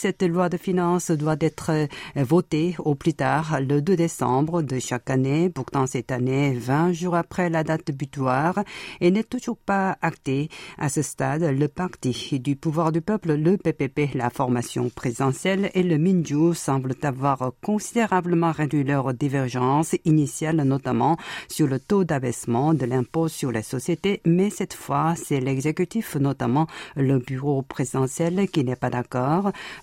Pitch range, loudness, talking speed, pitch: 135-175 Hz, -24 LUFS, 155 wpm, 155 Hz